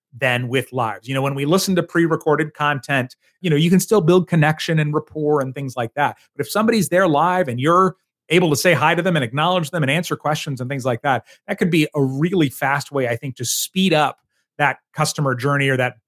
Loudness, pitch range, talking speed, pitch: -19 LUFS, 135-175 Hz, 245 wpm, 150 Hz